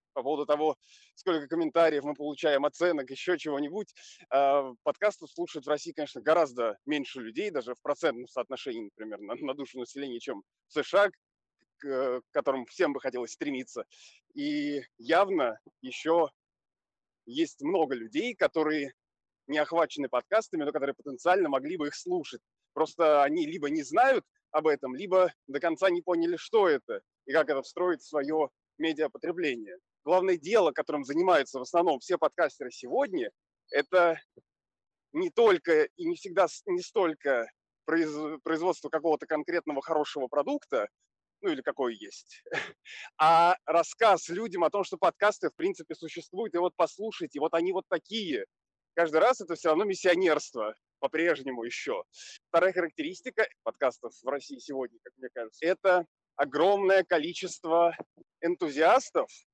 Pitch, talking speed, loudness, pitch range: 165 Hz, 140 wpm, -29 LUFS, 145-195 Hz